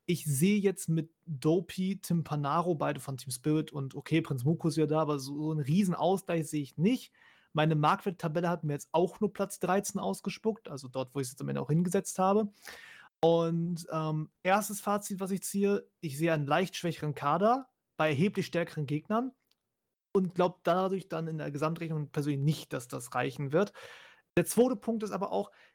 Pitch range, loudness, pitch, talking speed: 155-195 Hz, -31 LUFS, 170 Hz, 190 wpm